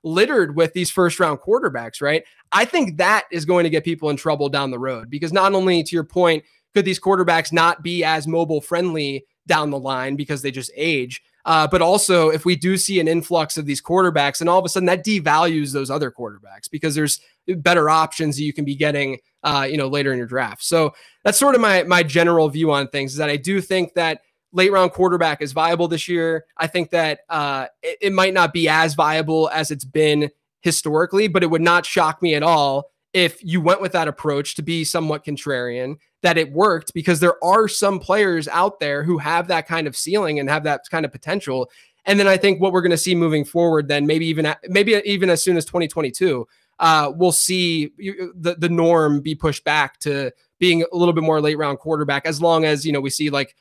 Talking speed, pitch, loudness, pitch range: 225 wpm, 165 Hz, -19 LUFS, 150-180 Hz